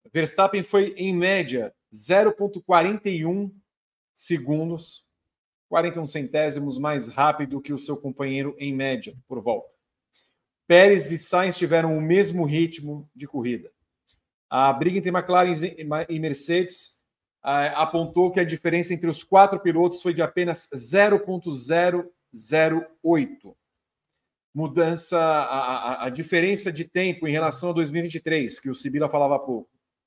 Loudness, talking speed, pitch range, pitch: -23 LUFS, 125 wpm, 145-180 Hz, 165 Hz